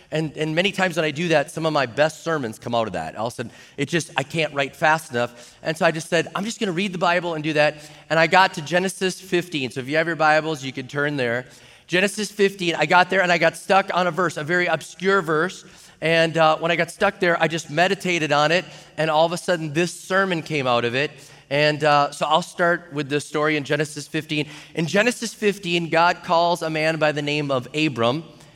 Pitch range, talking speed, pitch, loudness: 150-175 Hz, 255 wpm, 160 Hz, -21 LUFS